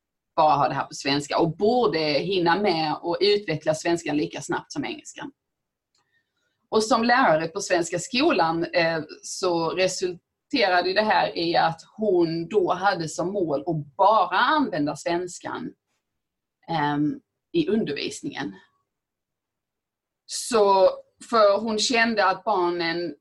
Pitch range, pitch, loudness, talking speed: 165-215 Hz, 180 Hz, -23 LUFS, 120 wpm